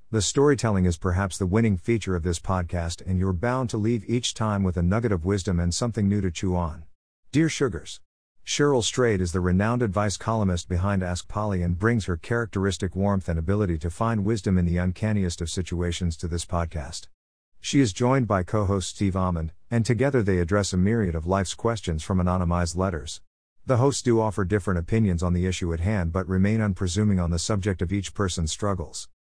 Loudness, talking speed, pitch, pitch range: -25 LUFS, 200 wpm, 95 Hz, 90-110 Hz